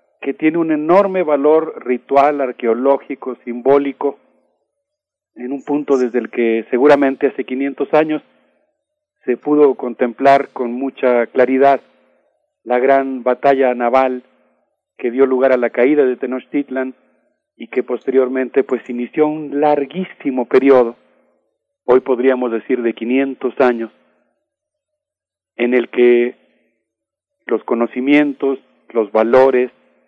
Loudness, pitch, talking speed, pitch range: -16 LUFS, 130 Hz, 115 wpm, 125-145 Hz